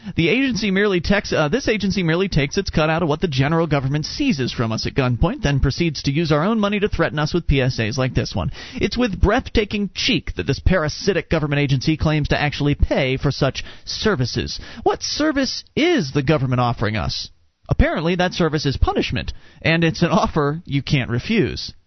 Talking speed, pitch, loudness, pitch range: 200 wpm, 155 Hz, -20 LUFS, 135-190 Hz